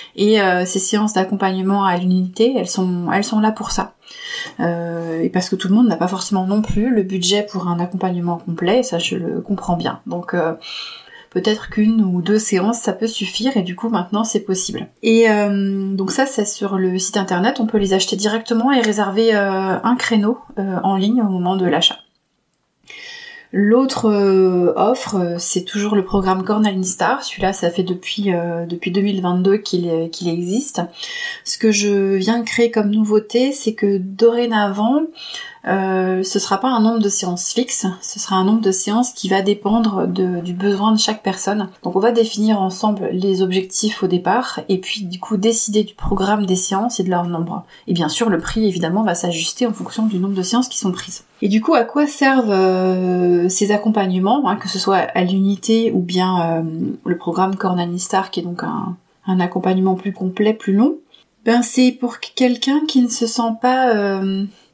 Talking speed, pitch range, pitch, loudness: 200 wpm, 185-225 Hz, 200 Hz, -17 LUFS